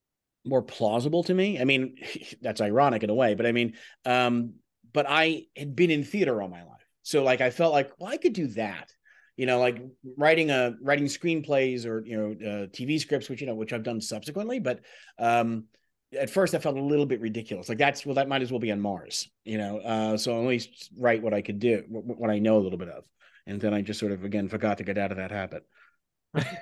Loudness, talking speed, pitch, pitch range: -27 LUFS, 240 wpm, 125 Hz, 110-145 Hz